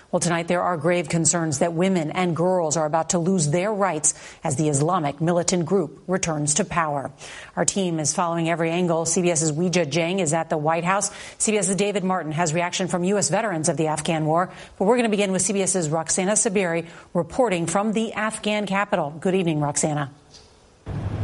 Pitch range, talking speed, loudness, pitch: 165-190 Hz, 190 wpm, -22 LUFS, 175 Hz